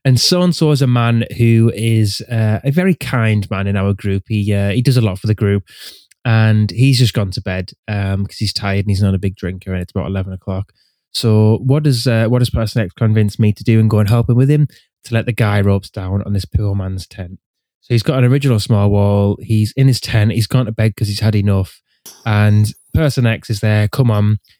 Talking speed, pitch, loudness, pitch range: 250 wpm, 110 Hz, -15 LUFS, 100-120 Hz